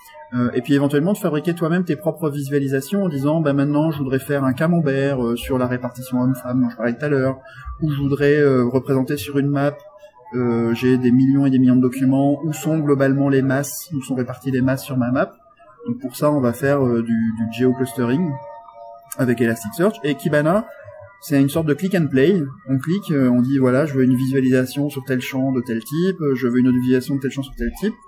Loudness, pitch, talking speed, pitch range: -19 LUFS, 135 Hz, 220 wpm, 125-145 Hz